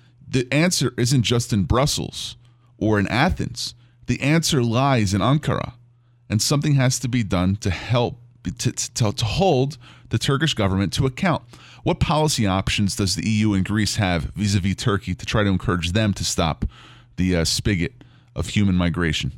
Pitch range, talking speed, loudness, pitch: 100-130 Hz, 175 wpm, -21 LUFS, 120 Hz